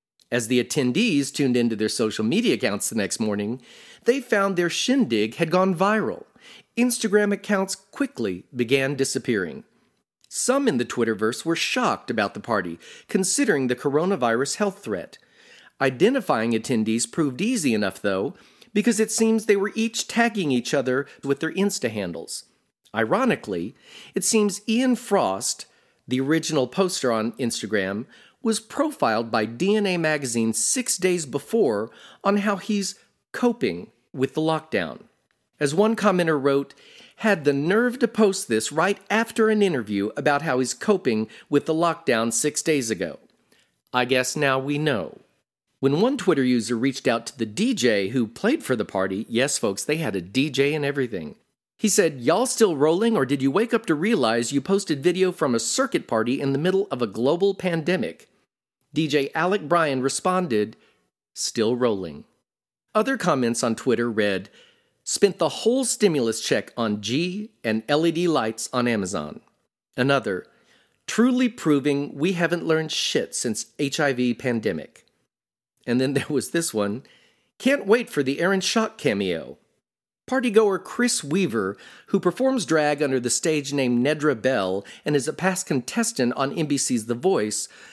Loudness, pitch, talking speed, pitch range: -23 LUFS, 155 Hz, 155 wpm, 125-205 Hz